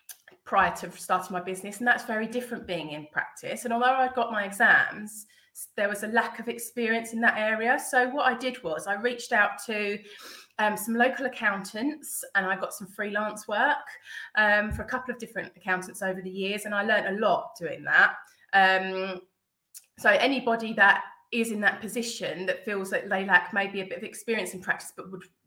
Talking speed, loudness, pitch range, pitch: 200 wpm, -26 LUFS, 195-235 Hz, 210 Hz